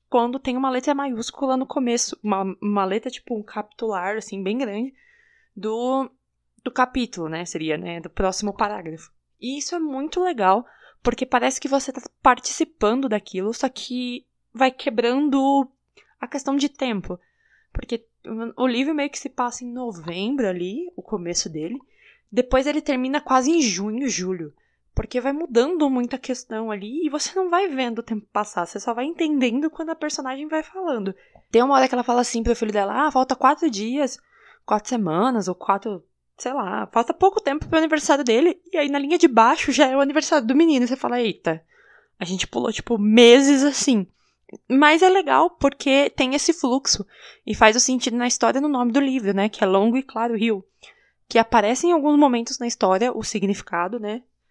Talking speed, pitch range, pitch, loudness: 185 wpm, 215-280 Hz, 250 Hz, -21 LUFS